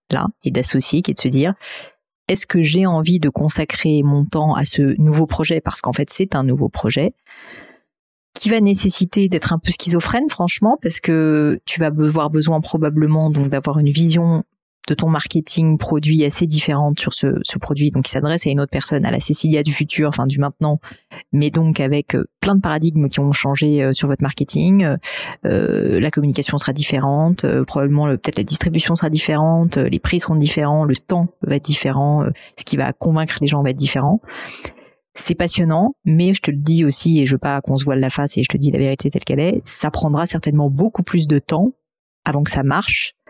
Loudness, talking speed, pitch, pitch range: -17 LUFS, 215 wpm, 155 Hz, 145-170 Hz